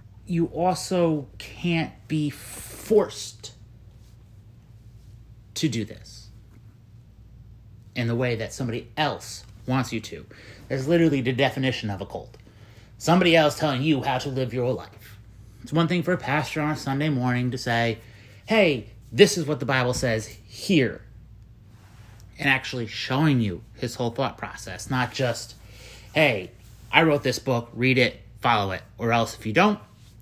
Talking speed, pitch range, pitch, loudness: 155 wpm, 110-135 Hz, 115 Hz, -24 LUFS